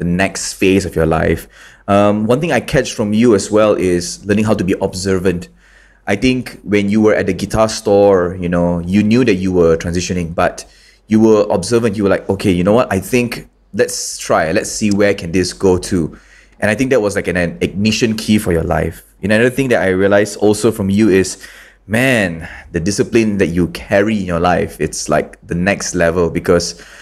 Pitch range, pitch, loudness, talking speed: 90-110 Hz, 100 Hz, -14 LUFS, 220 wpm